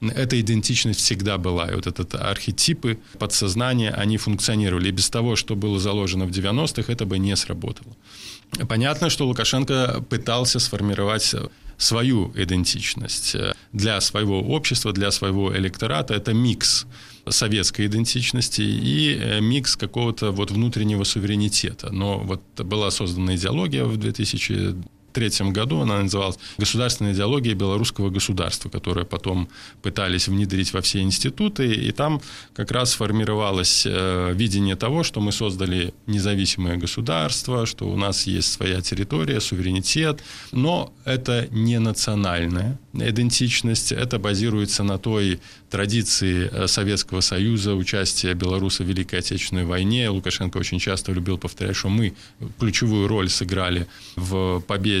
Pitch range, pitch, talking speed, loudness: 95-115 Hz, 105 Hz, 130 wpm, -22 LUFS